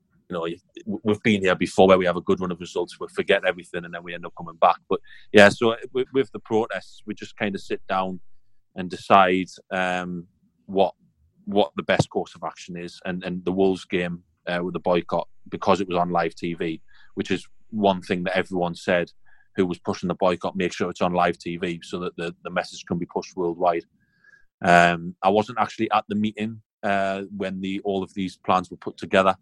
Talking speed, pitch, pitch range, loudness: 215 wpm, 95 Hz, 85-100 Hz, -24 LUFS